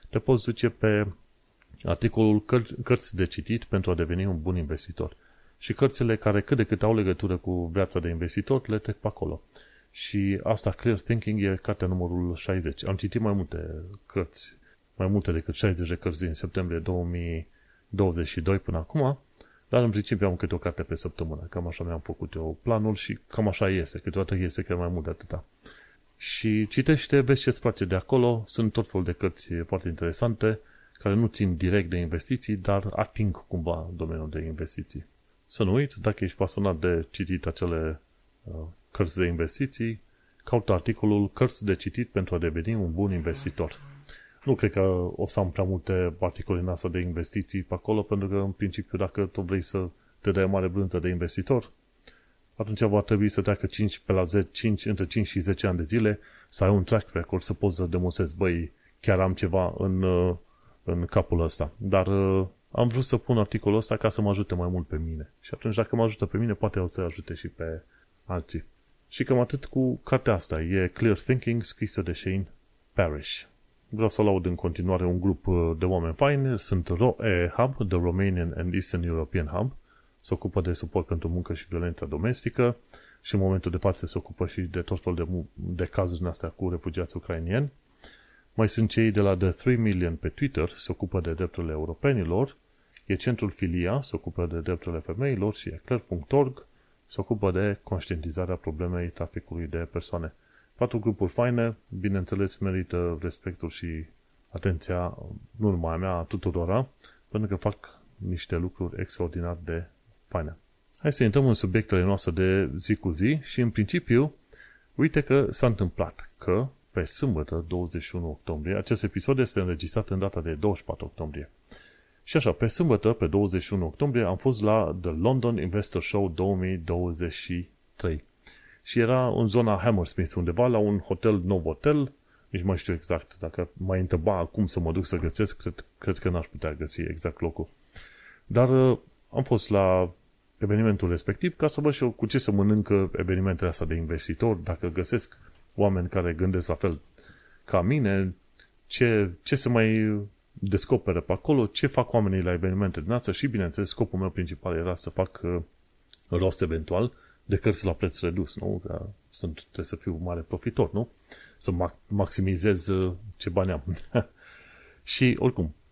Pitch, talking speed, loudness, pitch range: 95 Hz, 180 wpm, -28 LUFS, 90-110 Hz